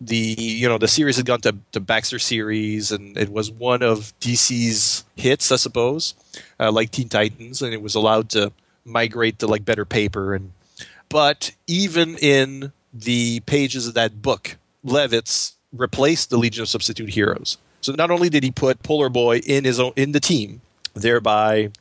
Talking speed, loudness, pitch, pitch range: 180 wpm, -20 LUFS, 115 Hz, 110-130 Hz